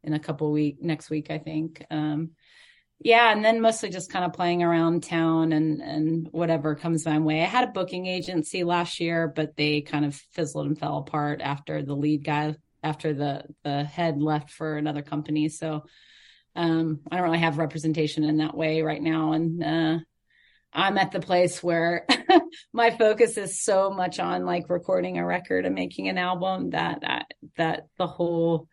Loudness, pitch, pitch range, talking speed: -25 LUFS, 160 Hz, 150-180 Hz, 190 wpm